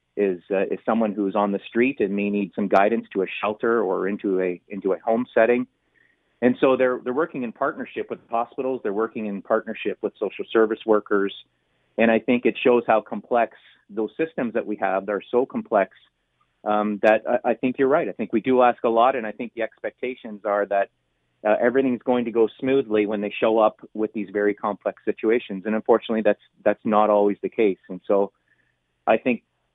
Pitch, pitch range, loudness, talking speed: 110 Hz, 100-120 Hz, -23 LUFS, 210 wpm